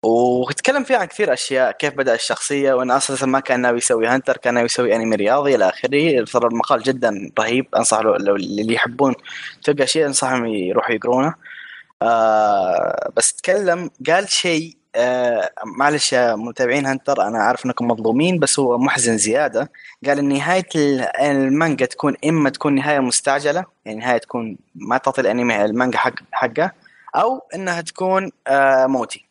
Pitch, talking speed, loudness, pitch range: 135 Hz, 160 wpm, -18 LUFS, 120-150 Hz